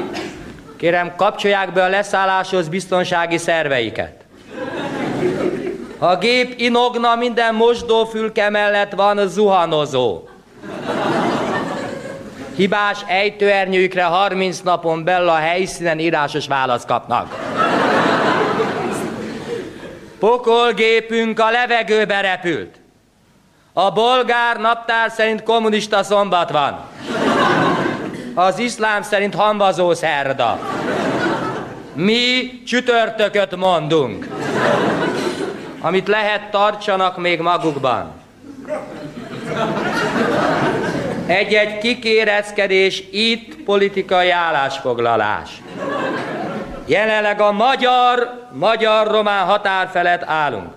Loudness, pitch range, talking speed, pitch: -17 LUFS, 175-225 Hz, 70 wpm, 200 Hz